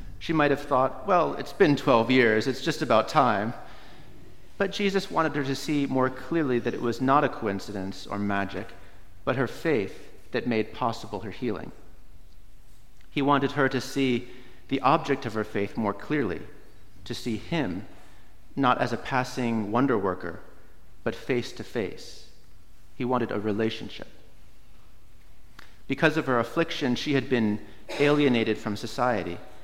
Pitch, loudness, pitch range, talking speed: 120 Hz, -26 LUFS, 100-135 Hz, 155 wpm